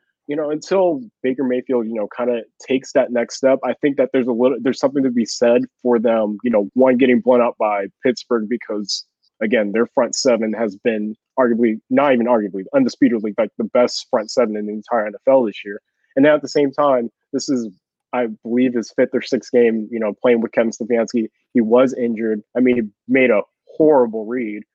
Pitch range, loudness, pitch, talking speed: 110-130 Hz, -18 LUFS, 120 Hz, 215 wpm